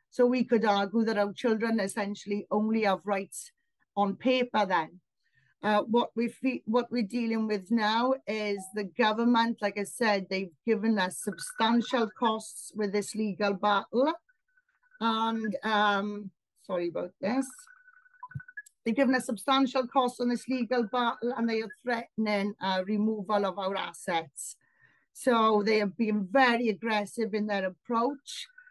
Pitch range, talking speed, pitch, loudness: 205-245 Hz, 145 wpm, 225 Hz, -29 LUFS